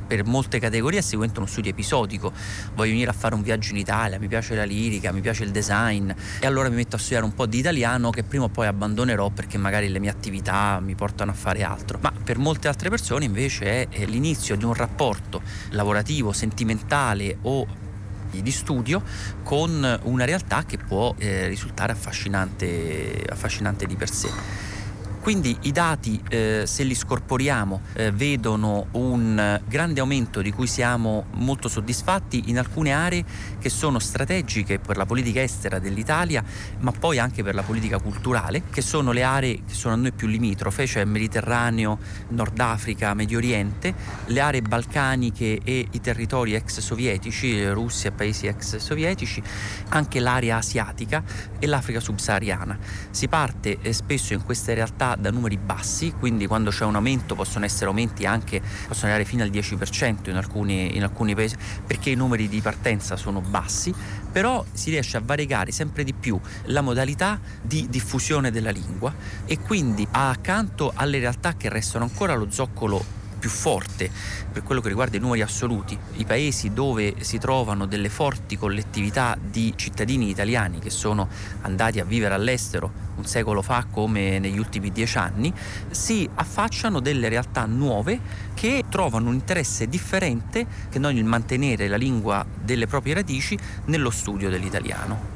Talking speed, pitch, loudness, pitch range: 160 wpm, 110 Hz, -24 LUFS, 100-125 Hz